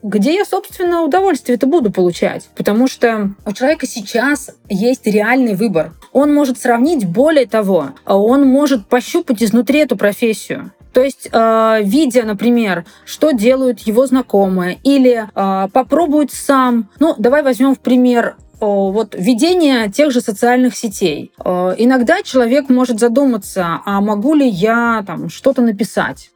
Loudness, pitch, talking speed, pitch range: -14 LUFS, 245 Hz, 135 wpm, 215-270 Hz